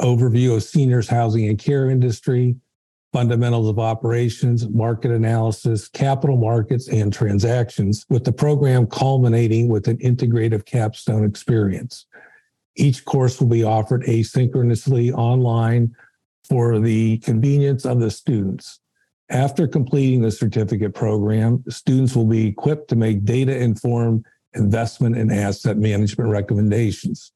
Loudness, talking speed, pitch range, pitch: -19 LUFS, 125 wpm, 110-125 Hz, 115 Hz